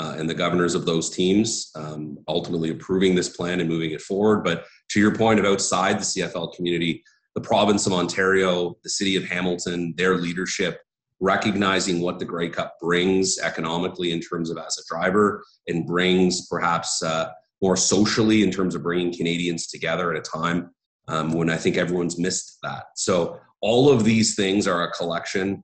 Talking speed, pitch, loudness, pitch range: 185 wpm, 90 Hz, -22 LUFS, 85-95 Hz